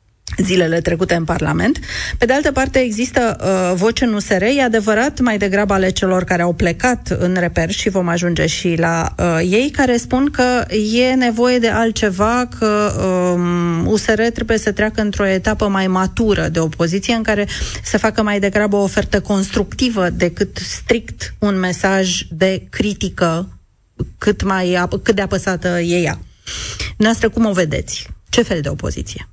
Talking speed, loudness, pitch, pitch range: 165 wpm, -16 LUFS, 200 Hz, 180-225 Hz